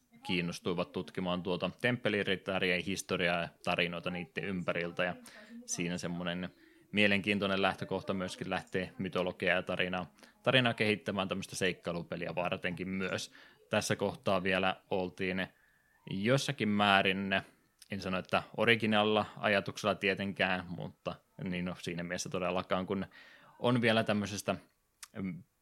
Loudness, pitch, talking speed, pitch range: -33 LUFS, 95 Hz, 110 wpm, 90-105 Hz